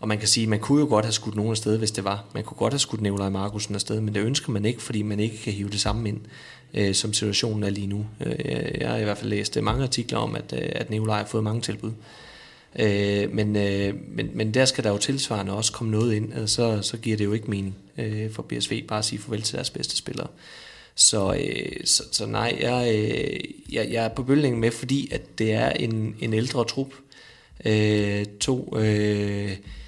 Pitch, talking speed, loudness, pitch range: 110 Hz, 215 wpm, -25 LUFS, 105-115 Hz